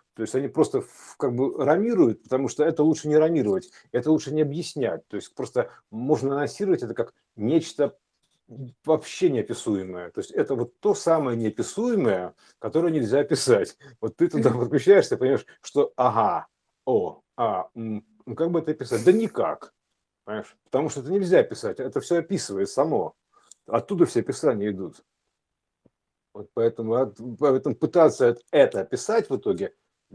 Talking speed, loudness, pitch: 150 wpm, -24 LUFS, 155 Hz